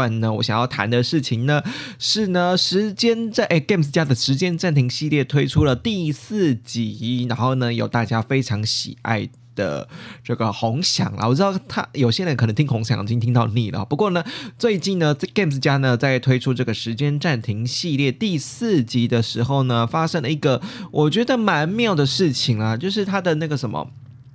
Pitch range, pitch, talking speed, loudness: 120-170 Hz, 135 Hz, 300 characters per minute, -20 LUFS